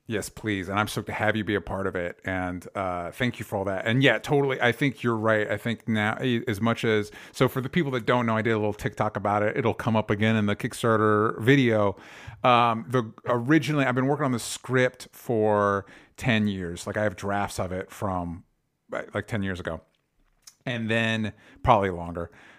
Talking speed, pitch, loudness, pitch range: 220 wpm, 110 Hz, -25 LUFS, 100-120 Hz